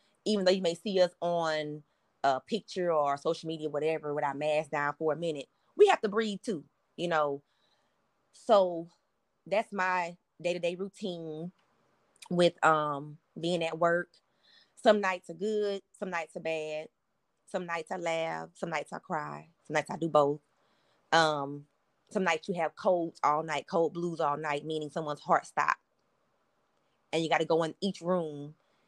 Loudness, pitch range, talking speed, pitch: -31 LUFS, 150-180 Hz, 170 wpm, 165 Hz